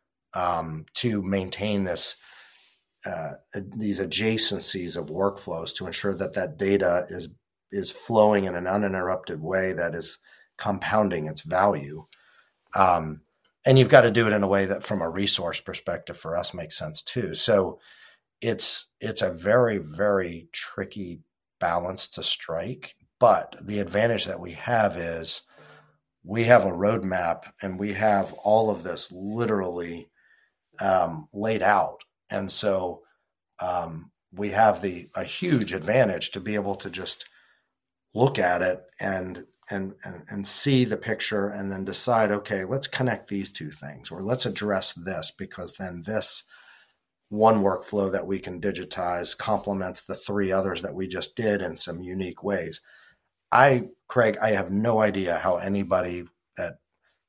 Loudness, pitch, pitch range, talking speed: -25 LUFS, 100 Hz, 90-105 Hz, 150 wpm